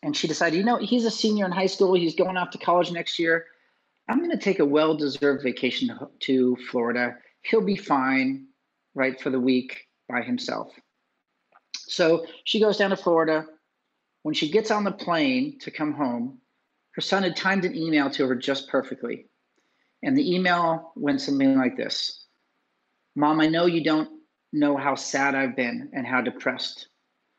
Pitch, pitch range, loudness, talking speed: 165 Hz, 140-210 Hz, -24 LUFS, 180 wpm